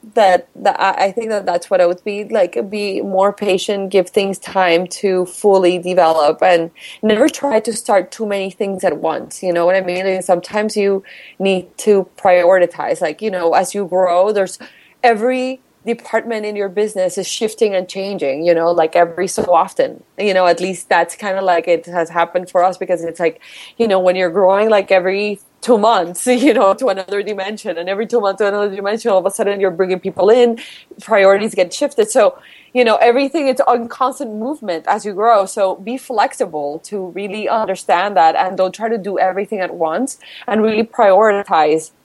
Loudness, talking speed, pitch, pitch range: -15 LUFS, 200 wpm, 195 Hz, 185-220 Hz